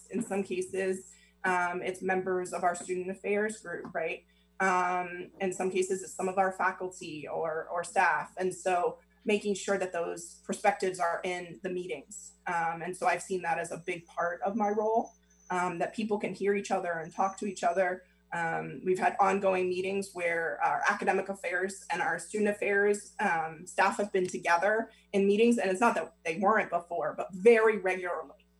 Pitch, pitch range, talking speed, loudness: 185 Hz, 175-200 Hz, 190 wpm, -31 LUFS